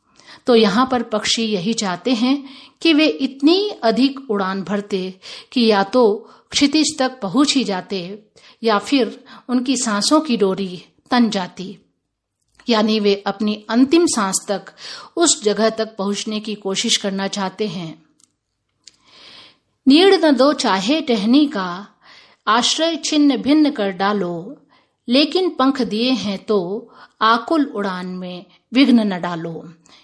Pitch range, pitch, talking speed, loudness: 195-265 Hz, 225 Hz, 130 wpm, -17 LUFS